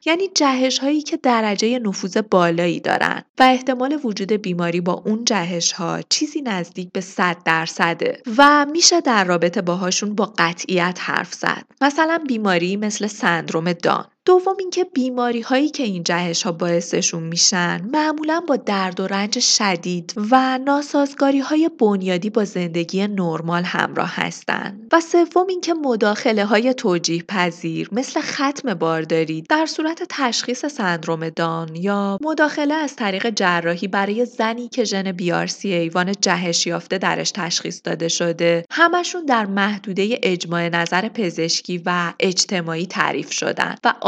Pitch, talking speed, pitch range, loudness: 205 Hz, 140 wpm, 175-260 Hz, -19 LUFS